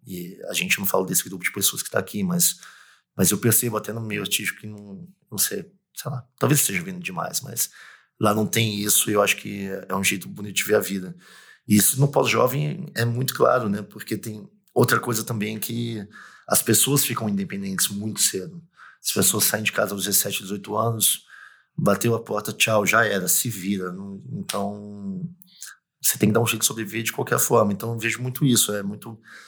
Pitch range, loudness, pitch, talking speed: 105-140 Hz, -22 LUFS, 115 Hz, 210 wpm